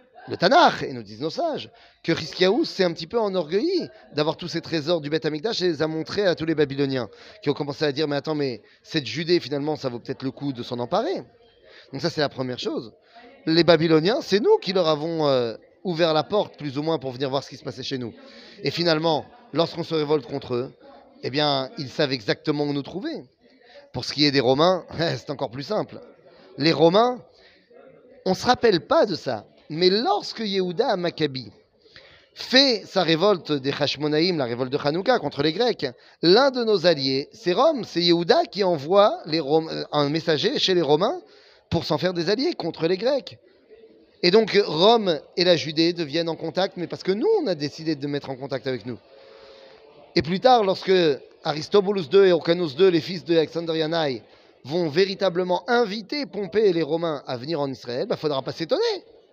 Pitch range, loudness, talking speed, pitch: 145-195 Hz, -23 LUFS, 205 wpm, 165 Hz